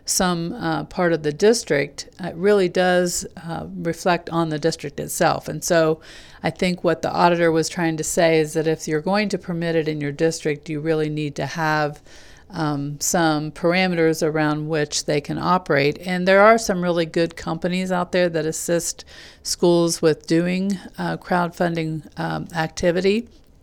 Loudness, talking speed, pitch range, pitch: -21 LUFS, 175 wpm, 155-180 Hz, 165 Hz